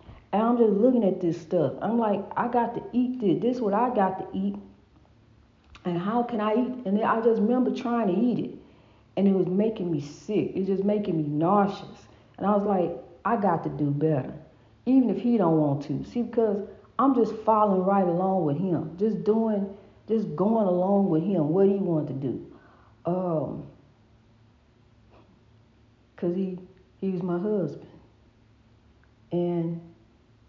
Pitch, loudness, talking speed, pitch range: 190 Hz, -26 LUFS, 180 wpm, 150-215 Hz